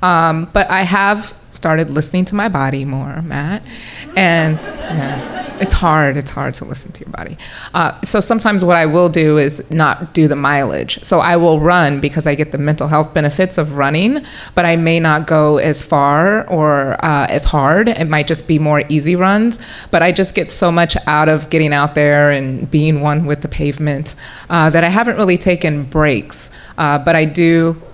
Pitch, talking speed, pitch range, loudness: 160 Hz, 200 wpm, 150-175 Hz, -13 LUFS